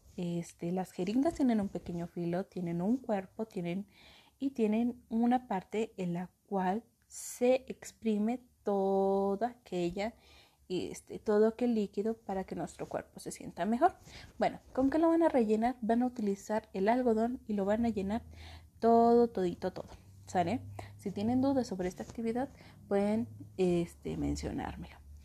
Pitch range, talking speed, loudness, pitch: 180-235 Hz, 150 wpm, -33 LUFS, 205 Hz